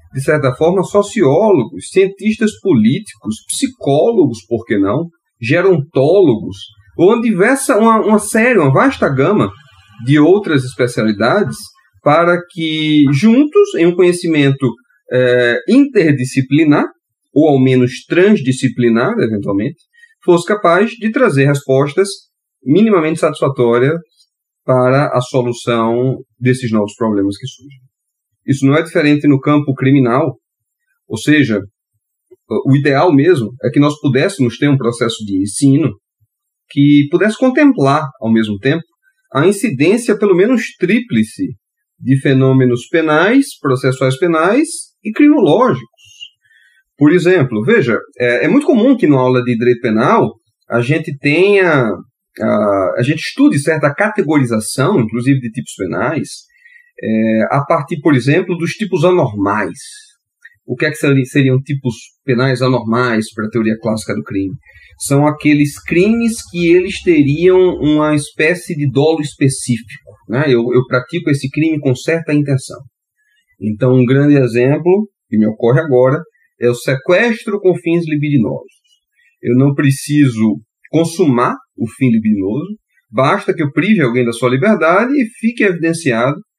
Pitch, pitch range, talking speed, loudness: 145 Hz, 125-185 Hz, 130 wpm, -13 LUFS